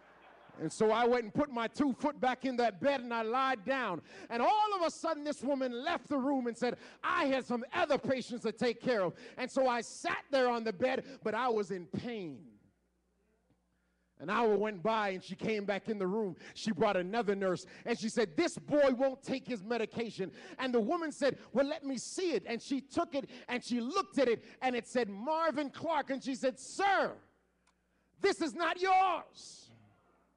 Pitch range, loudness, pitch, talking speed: 220-280 Hz, -34 LUFS, 245 Hz, 210 wpm